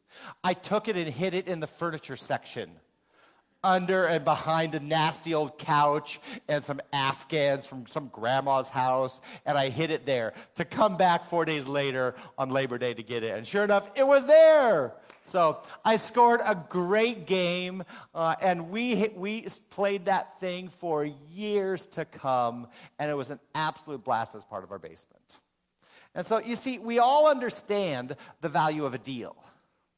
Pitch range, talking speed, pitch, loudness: 145-200 Hz, 175 wpm, 160 Hz, -27 LUFS